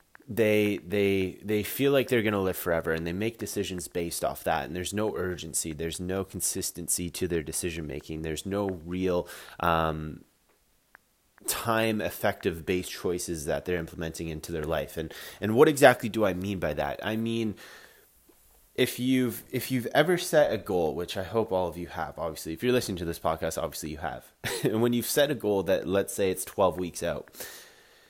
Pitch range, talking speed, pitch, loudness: 85-110 Hz, 210 wpm, 95 Hz, -28 LUFS